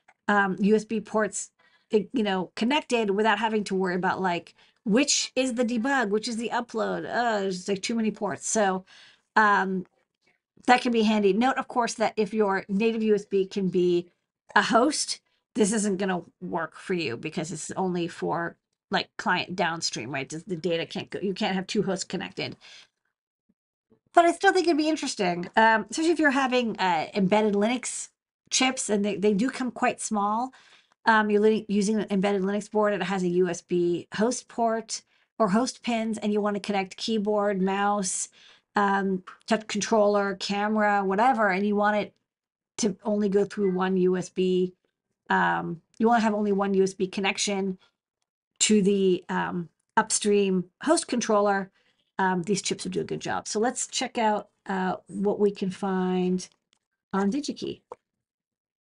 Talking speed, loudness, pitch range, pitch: 170 wpm, -26 LUFS, 190-225 Hz, 205 Hz